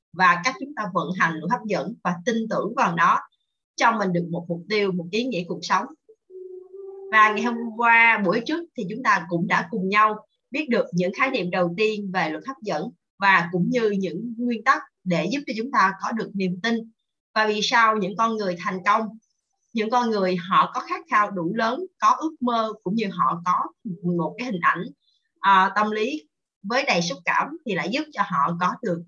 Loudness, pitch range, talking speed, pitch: -23 LUFS, 185-245 Hz, 220 wpm, 215 Hz